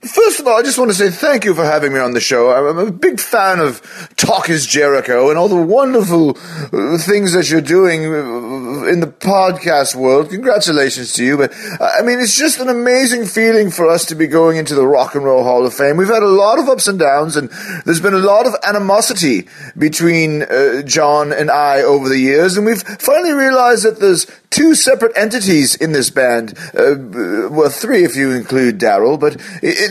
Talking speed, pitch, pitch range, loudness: 210 wpm, 170 Hz, 145-225 Hz, -12 LUFS